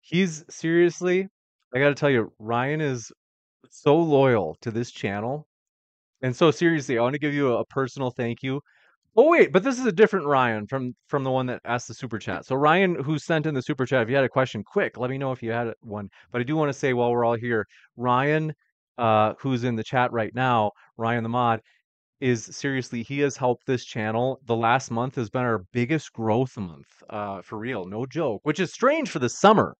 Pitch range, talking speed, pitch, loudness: 115-145 Hz, 225 wpm, 130 Hz, -24 LUFS